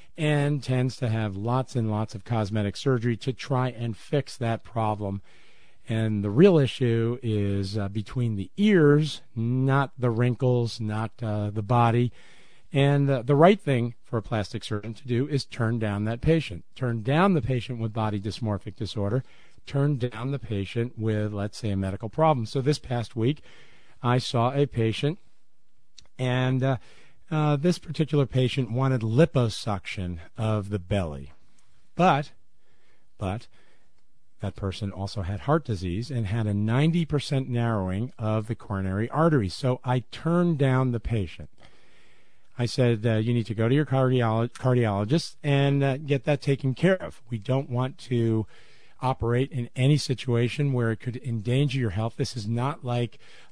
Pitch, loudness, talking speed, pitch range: 120 Hz, -26 LUFS, 160 wpm, 110-135 Hz